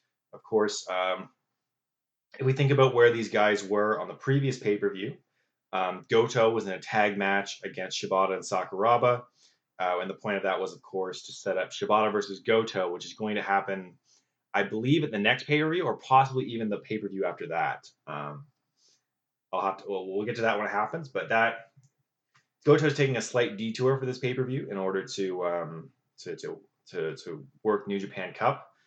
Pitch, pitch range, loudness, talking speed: 110 Hz, 95-130 Hz, -28 LUFS, 210 wpm